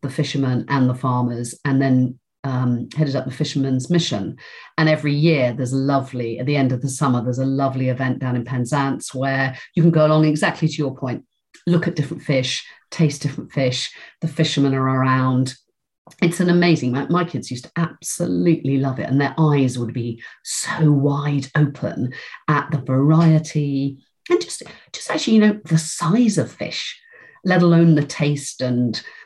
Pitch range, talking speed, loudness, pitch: 130-160 Hz, 185 wpm, -20 LUFS, 140 Hz